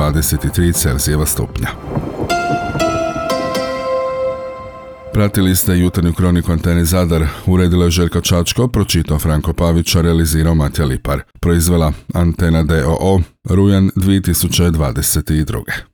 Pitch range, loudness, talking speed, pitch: 80-100 Hz, -15 LUFS, 90 wpm, 85 Hz